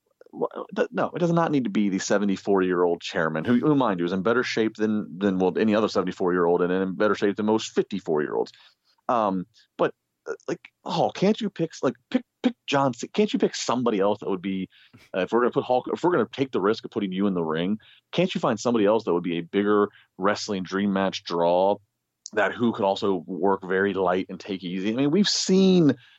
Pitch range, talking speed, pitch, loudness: 95-135 Hz, 220 wpm, 100 Hz, -24 LUFS